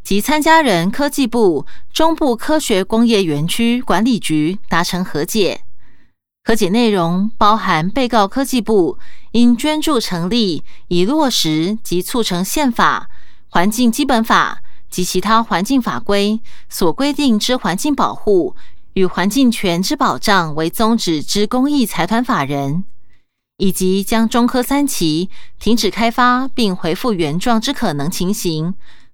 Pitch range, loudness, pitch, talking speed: 180-250 Hz, -16 LUFS, 215 Hz, 215 characters per minute